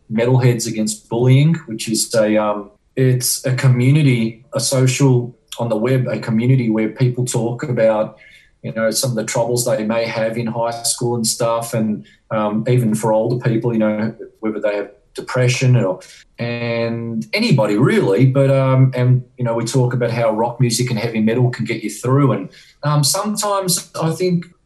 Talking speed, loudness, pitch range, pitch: 180 wpm, -17 LUFS, 110-130 Hz, 120 Hz